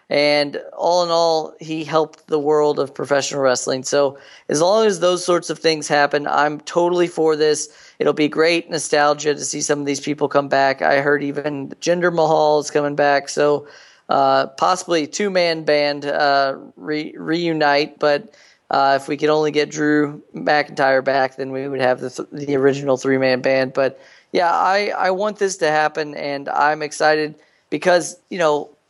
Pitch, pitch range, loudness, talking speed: 150 Hz, 140-160 Hz, -18 LUFS, 185 wpm